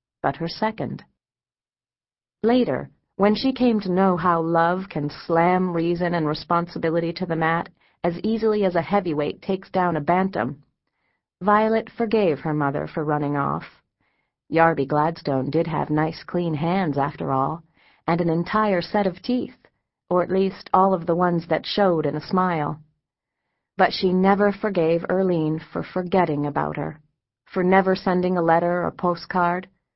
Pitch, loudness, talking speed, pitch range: 175 Hz, -22 LUFS, 155 wpm, 155-190 Hz